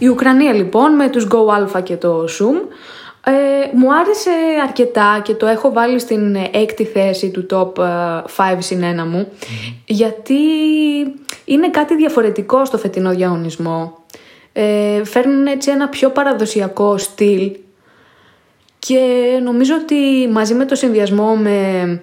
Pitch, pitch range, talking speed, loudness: 225 Hz, 195-275 Hz, 130 wpm, -14 LUFS